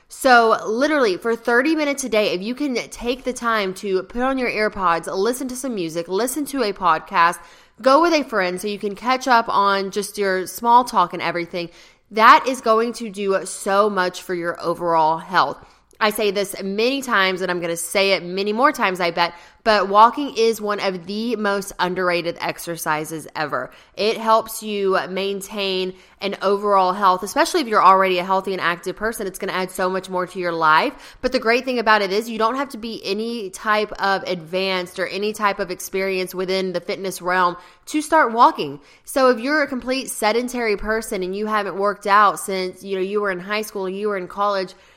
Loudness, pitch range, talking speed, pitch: -20 LUFS, 185-225 Hz, 210 wpm, 200 Hz